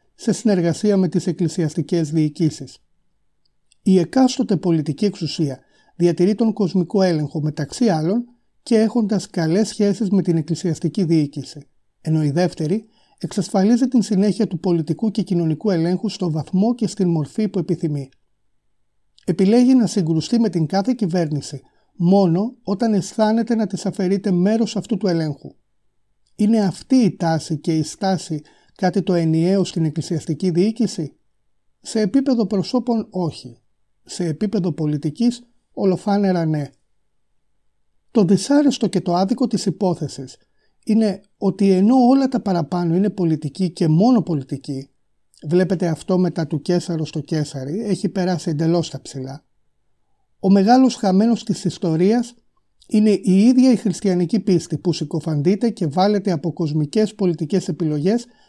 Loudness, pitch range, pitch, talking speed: -19 LUFS, 160-210 Hz, 185 Hz, 135 wpm